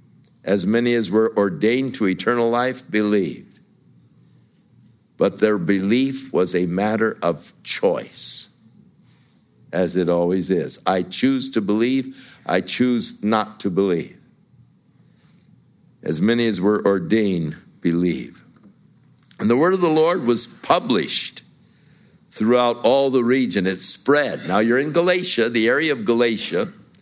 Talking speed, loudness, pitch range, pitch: 130 wpm, -20 LUFS, 100-125 Hz, 110 Hz